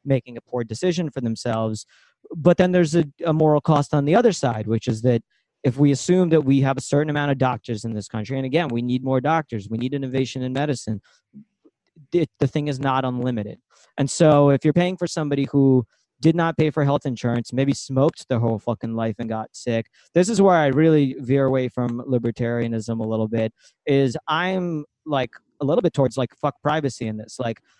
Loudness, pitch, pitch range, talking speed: -21 LUFS, 135 Hz, 120-155 Hz, 215 wpm